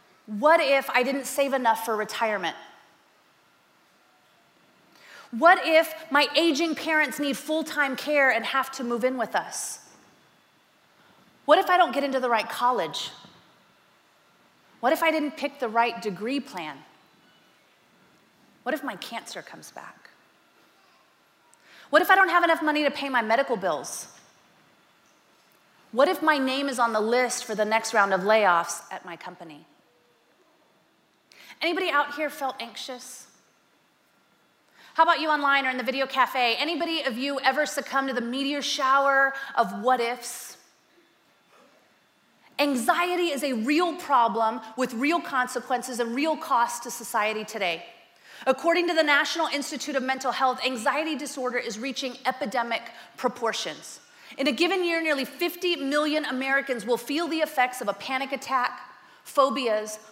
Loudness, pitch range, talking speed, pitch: -25 LUFS, 240-300 Hz, 150 wpm, 270 Hz